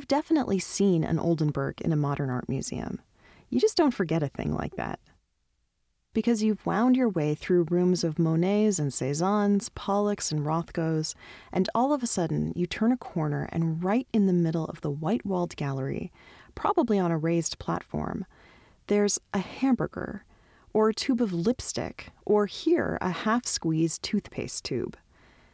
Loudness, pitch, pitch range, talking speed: -27 LUFS, 180 Hz, 160-215 Hz, 160 wpm